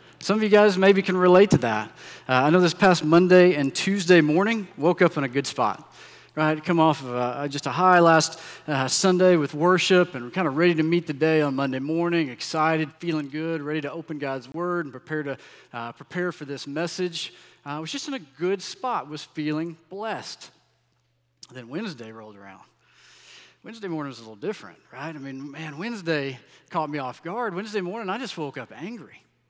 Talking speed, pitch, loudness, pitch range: 210 wpm, 160 Hz, -23 LUFS, 140-180 Hz